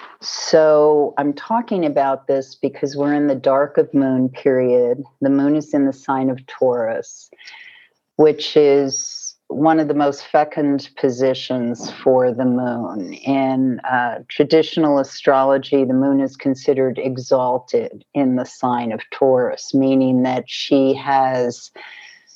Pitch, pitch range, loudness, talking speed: 135 Hz, 130-145 Hz, -18 LUFS, 135 wpm